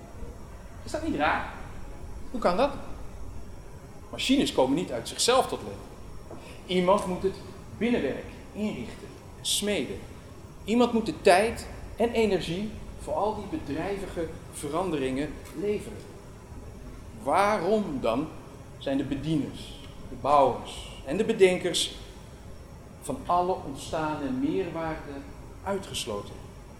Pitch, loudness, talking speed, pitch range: 175 Hz, -28 LUFS, 105 wpm, 135-205 Hz